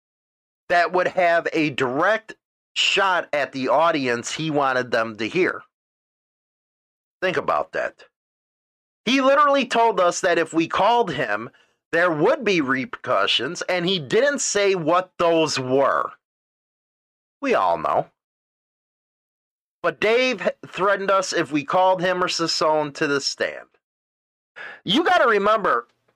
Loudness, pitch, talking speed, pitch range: -21 LUFS, 175 Hz, 130 wpm, 155-200 Hz